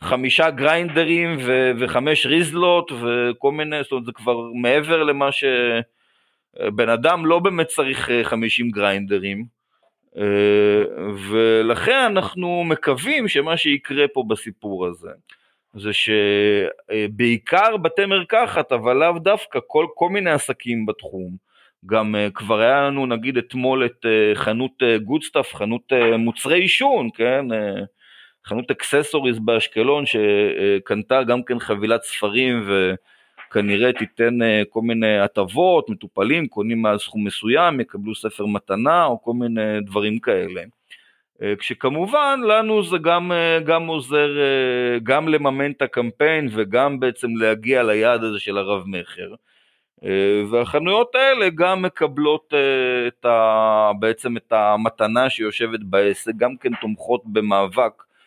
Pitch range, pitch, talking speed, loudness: 110-155 Hz, 125 Hz, 115 wpm, -19 LUFS